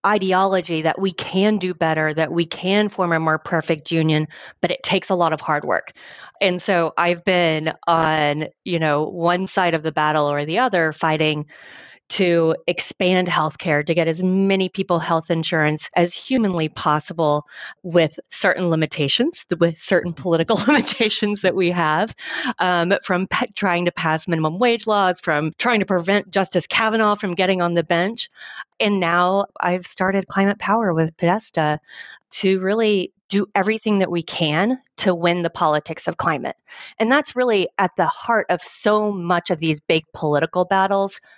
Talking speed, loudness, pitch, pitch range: 170 wpm, -20 LUFS, 180 Hz, 160-195 Hz